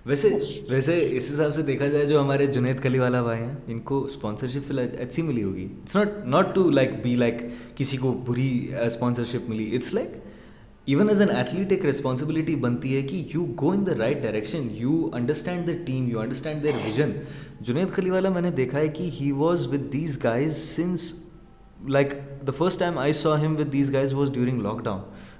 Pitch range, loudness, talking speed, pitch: 125-160 Hz, -25 LUFS, 200 wpm, 140 Hz